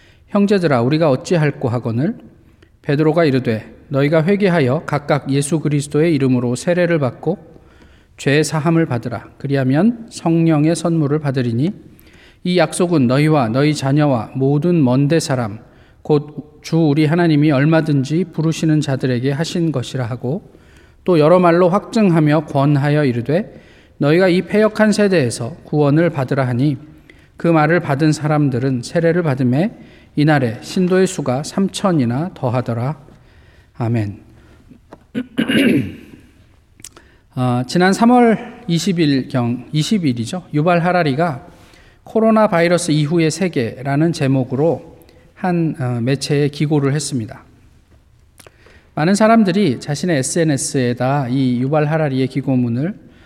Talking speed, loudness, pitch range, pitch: 280 characters per minute, -16 LUFS, 130-170 Hz, 150 Hz